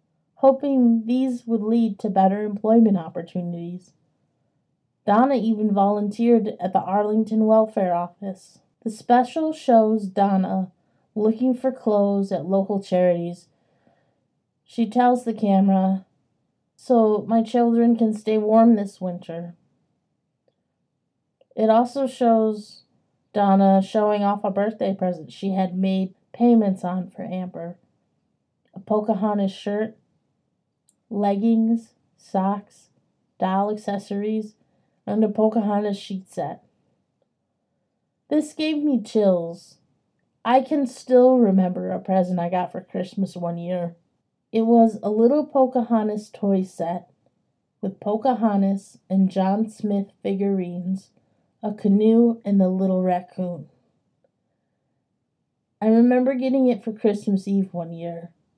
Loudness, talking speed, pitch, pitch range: -21 LUFS, 115 wpm, 205 Hz, 190-225 Hz